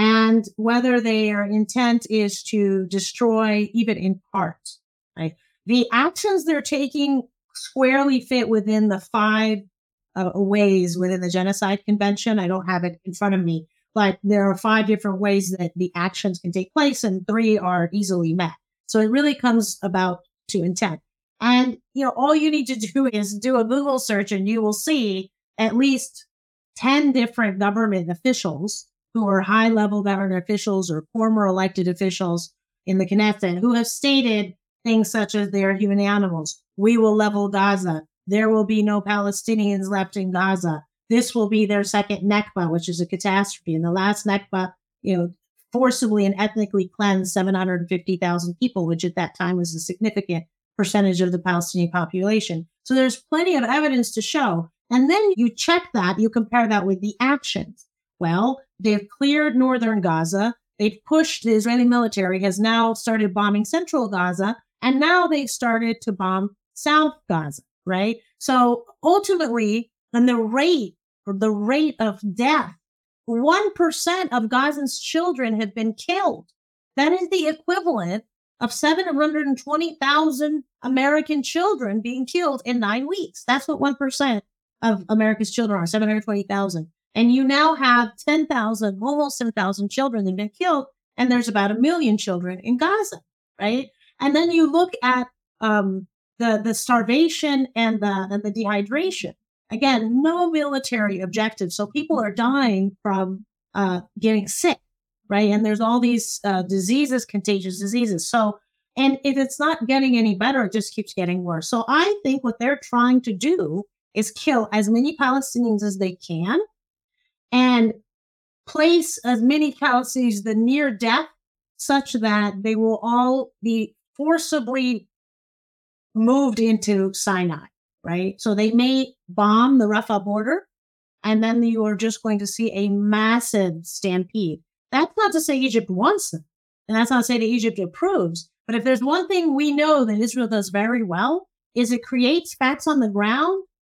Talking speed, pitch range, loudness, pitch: 165 wpm, 200-260 Hz, -21 LUFS, 220 Hz